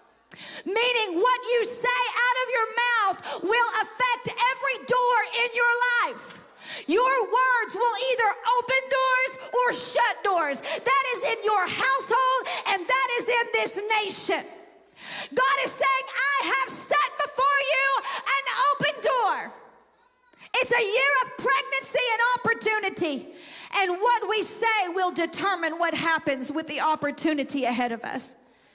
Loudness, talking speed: -24 LUFS, 140 wpm